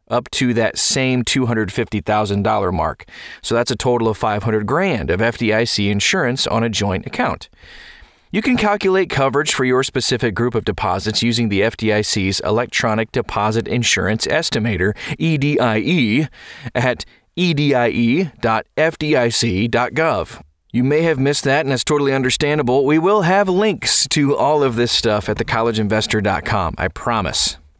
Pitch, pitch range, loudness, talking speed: 120 Hz, 110-145 Hz, -17 LUFS, 135 wpm